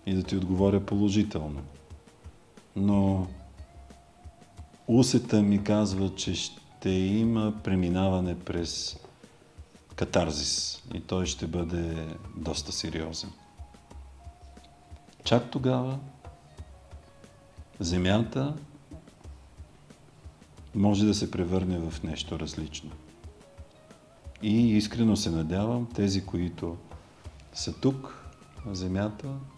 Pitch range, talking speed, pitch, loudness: 80-105 Hz, 80 wpm, 90 Hz, -28 LUFS